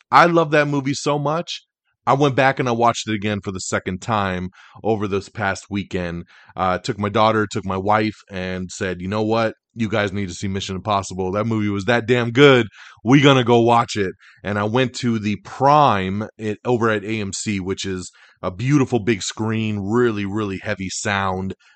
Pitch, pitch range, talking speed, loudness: 105 Hz, 95-120 Hz, 200 wpm, -20 LUFS